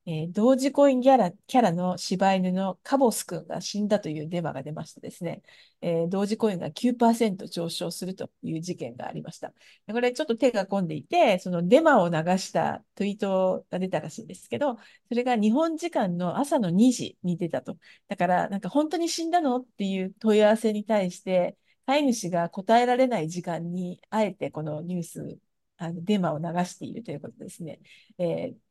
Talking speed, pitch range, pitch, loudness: 370 characters per minute, 175-245 Hz, 195 Hz, -26 LUFS